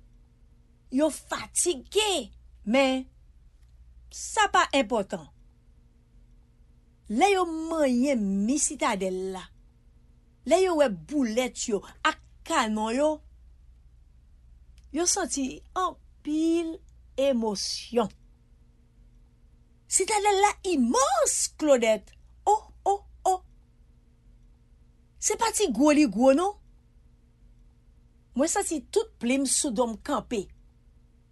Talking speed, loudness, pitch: 90 wpm, -26 LUFS, 220 Hz